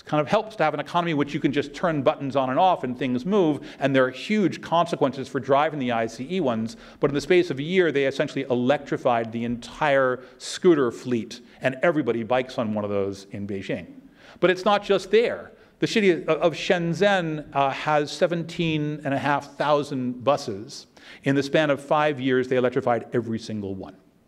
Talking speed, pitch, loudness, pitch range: 190 wpm, 145 Hz, -24 LUFS, 125-170 Hz